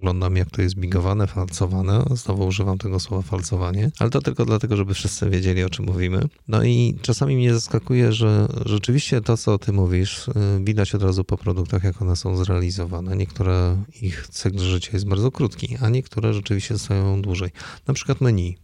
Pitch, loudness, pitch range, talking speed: 100 Hz, -22 LUFS, 95-115 Hz, 180 wpm